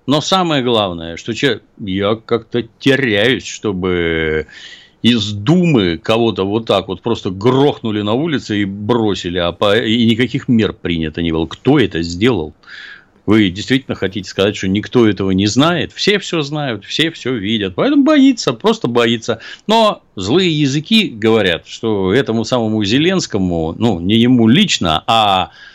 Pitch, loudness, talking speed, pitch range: 115 Hz, -15 LUFS, 150 wpm, 100-135 Hz